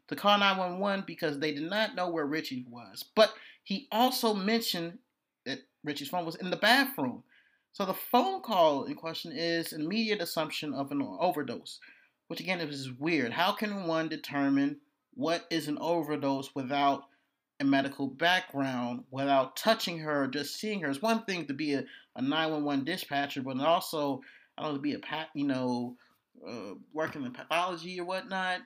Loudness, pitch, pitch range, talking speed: -31 LUFS, 165 Hz, 140-215 Hz, 170 wpm